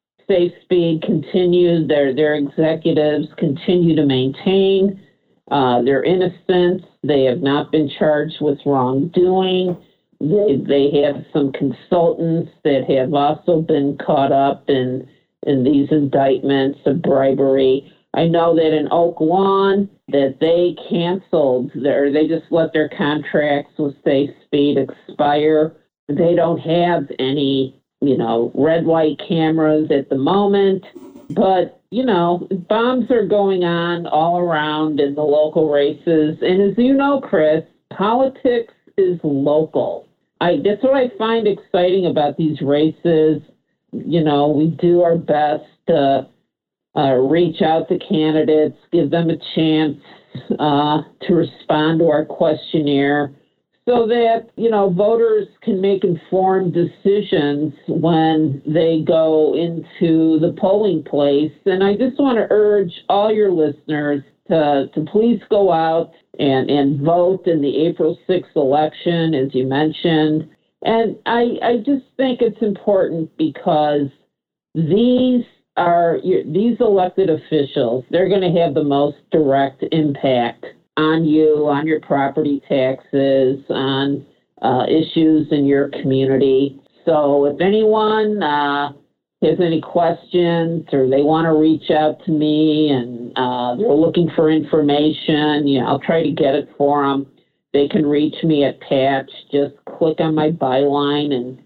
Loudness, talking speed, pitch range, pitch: -17 LUFS, 140 wpm, 145-180 Hz, 155 Hz